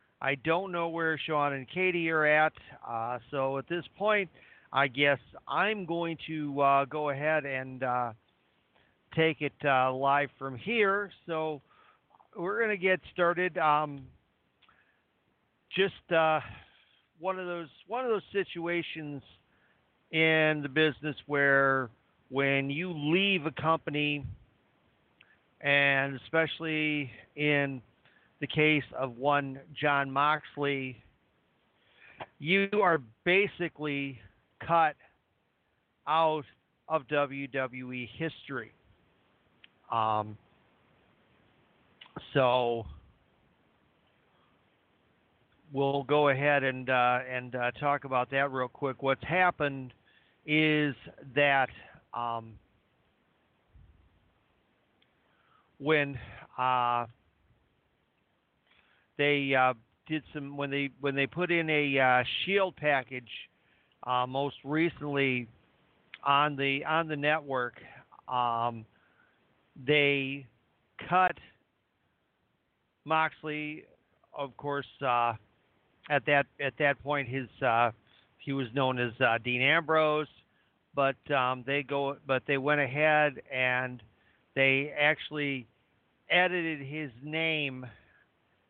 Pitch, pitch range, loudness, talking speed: 140 Hz, 130-155 Hz, -29 LUFS, 100 wpm